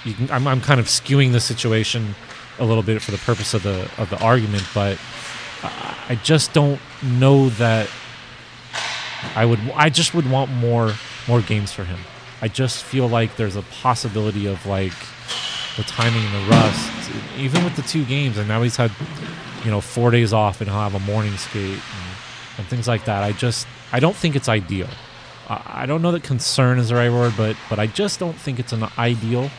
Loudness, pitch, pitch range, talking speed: -20 LUFS, 120 Hz, 110-130 Hz, 205 wpm